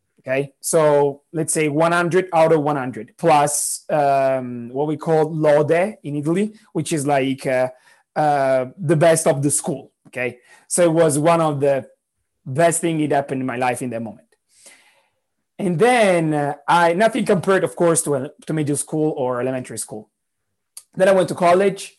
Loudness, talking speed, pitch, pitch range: -19 LUFS, 175 wpm, 155 Hz, 135-170 Hz